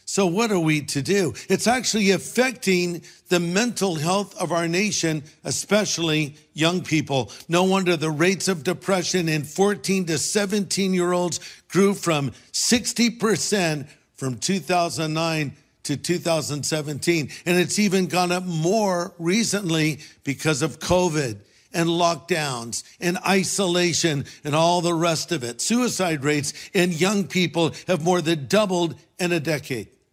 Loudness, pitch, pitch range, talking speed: -22 LUFS, 175 Hz, 155-190 Hz, 135 wpm